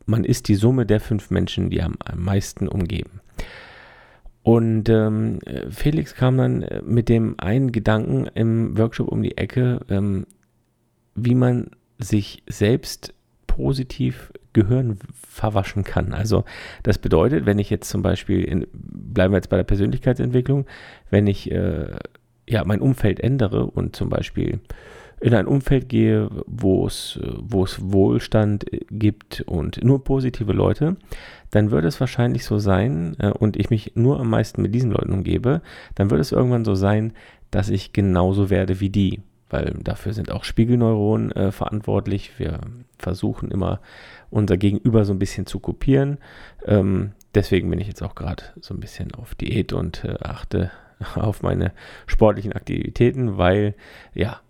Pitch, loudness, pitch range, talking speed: 105 Hz, -21 LUFS, 95-120 Hz, 155 wpm